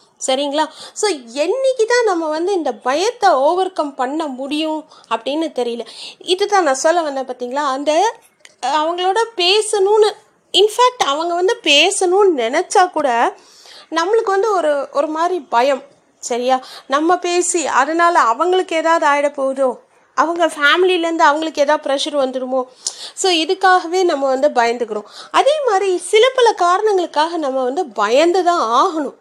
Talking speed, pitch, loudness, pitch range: 130 wpm, 325 Hz, -16 LUFS, 280-375 Hz